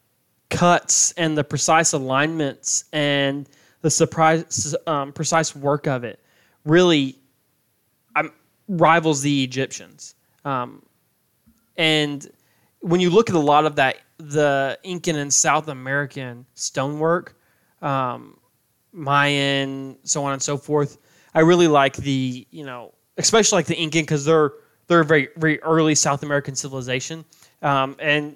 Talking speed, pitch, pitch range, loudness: 135 wpm, 145 Hz, 135-160 Hz, -20 LUFS